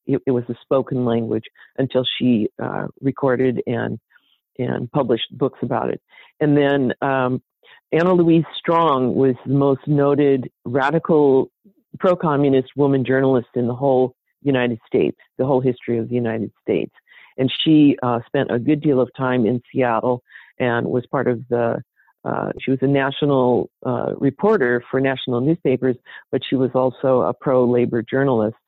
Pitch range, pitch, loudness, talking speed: 125-140 Hz, 130 Hz, -19 LUFS, 155 wpm